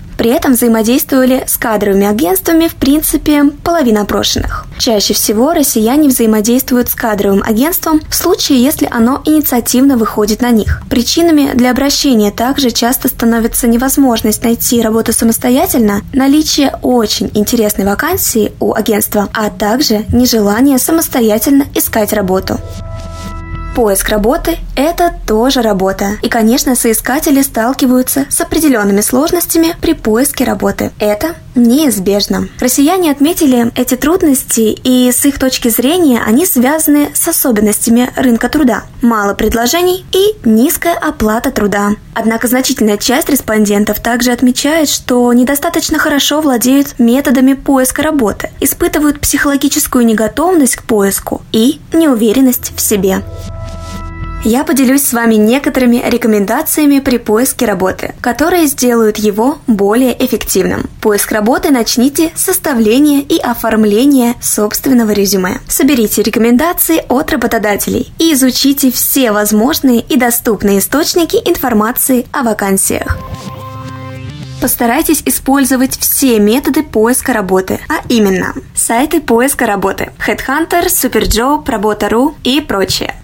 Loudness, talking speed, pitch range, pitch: -10 LUFS, 115 wpm, 220-285 Hz, 245 Hz